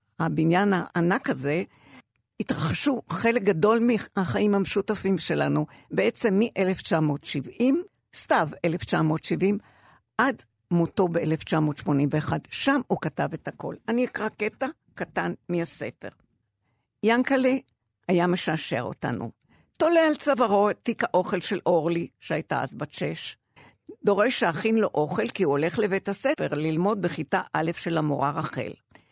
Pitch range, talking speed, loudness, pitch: 160-220 Hz, 120 wpm, -25 LUFS, 190 Hz